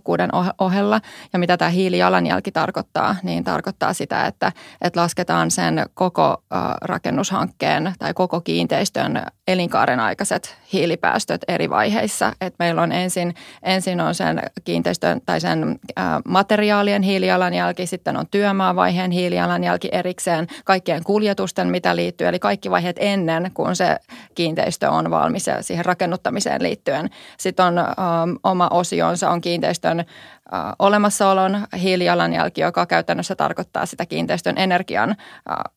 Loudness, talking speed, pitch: -20 LUFS, 115 wpm, 180 Hz